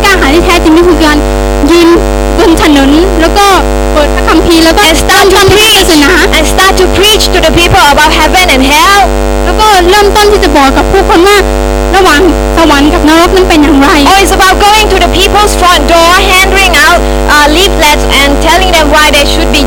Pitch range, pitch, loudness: 315-390 Hz, 355 Hz, -4 LUFS